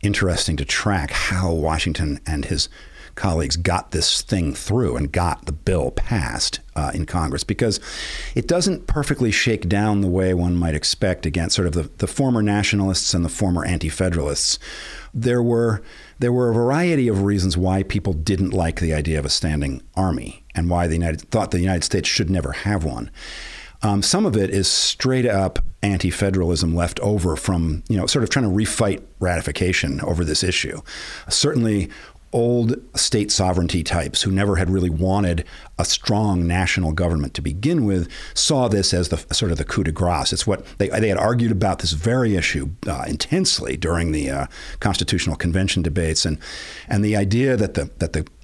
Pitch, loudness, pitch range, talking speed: 95 Hz, -20 LUFS, 85-105 Hz, 180 wpm